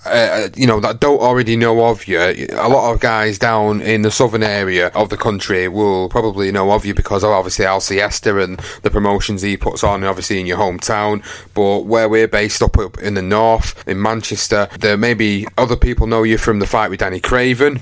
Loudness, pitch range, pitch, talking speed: -15 LUFS, 100-115 Hz, 105 Hz, 220 wpm